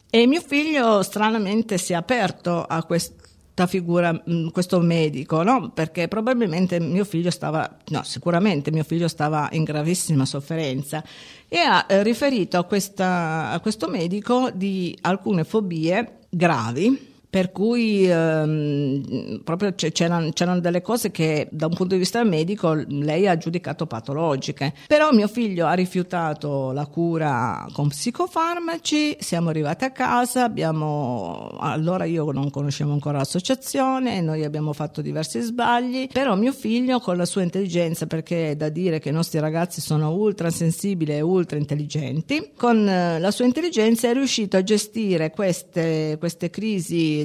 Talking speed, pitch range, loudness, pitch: 145 wpm, 155-215 Hz, -22 LUFS, 175 Hz